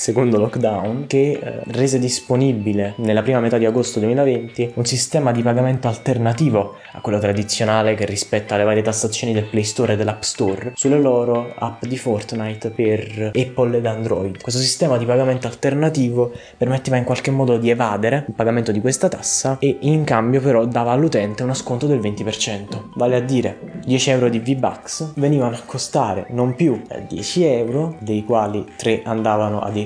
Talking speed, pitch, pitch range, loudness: 170 wpm, 120 Hz, 110-130 Hz, -19 LUFS